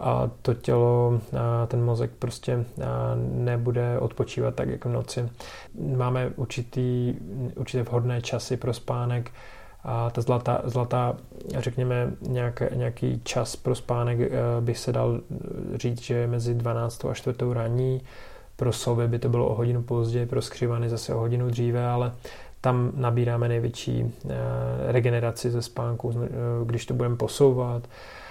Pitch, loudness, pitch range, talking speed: 120 Hz, -27 LUFS, 120-125 Hz, 135 wpm